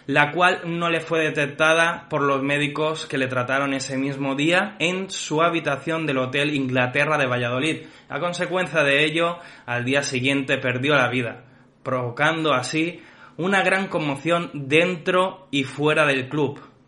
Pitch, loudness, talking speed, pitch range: 145 Hz, -22 LUFS, 155 wpm, 135-165 Hz